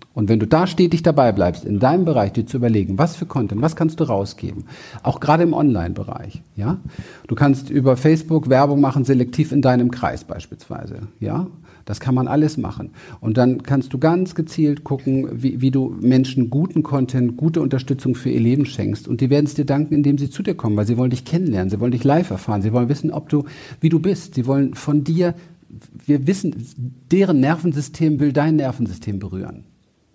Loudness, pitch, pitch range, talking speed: -19 LUFS, 135 Hz, 120-155 Hz, 205 wpm